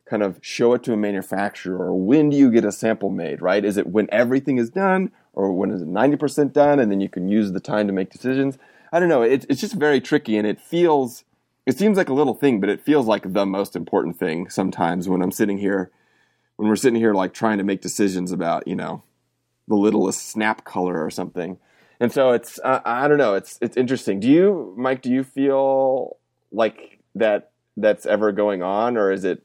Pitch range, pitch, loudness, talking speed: 95-135 Hz, 110 Hz, -20 LUFS, 230 wpm